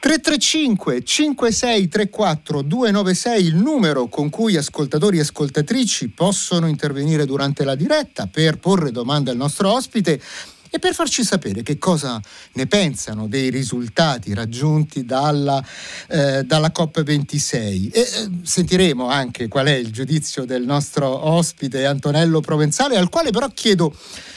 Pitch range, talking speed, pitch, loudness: 140-195 Hz, 125 wpm, 155 Hz, -18 LUFS